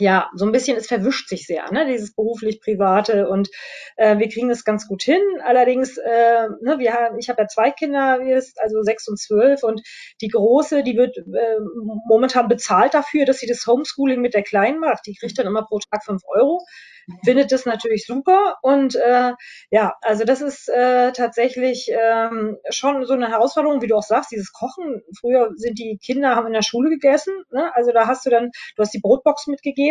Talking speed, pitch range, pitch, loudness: 205 wpm, 220-265 Hz, 240 Hz, -18 LUFS